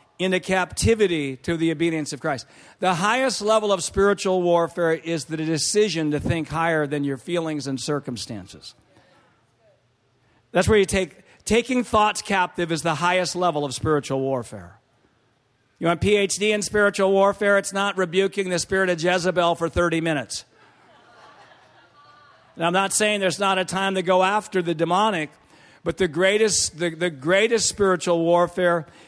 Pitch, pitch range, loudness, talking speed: 175 Hz, 160-195 Hz, -22 LUFS, 155 wpm